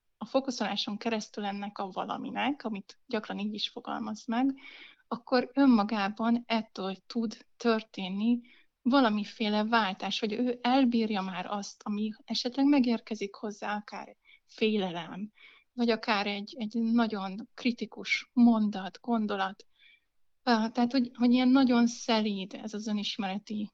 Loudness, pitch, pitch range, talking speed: -30 LUFS, 225 Hz, 205-240 Hz, 120 wpm